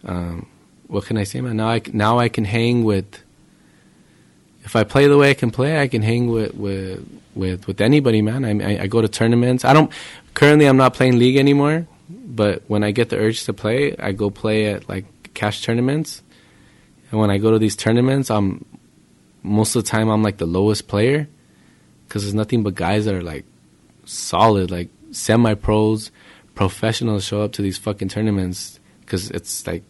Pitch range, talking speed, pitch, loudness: 100-120 Hz, 200 wpm, 110 Hz, -18 LUFS